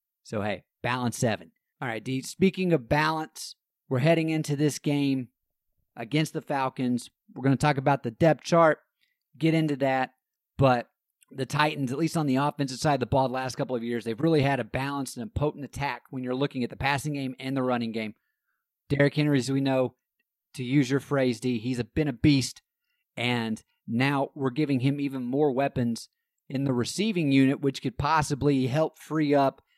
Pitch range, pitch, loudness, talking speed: 130-150 Hz, 140 Hz, -27 LUFS, 200 wpm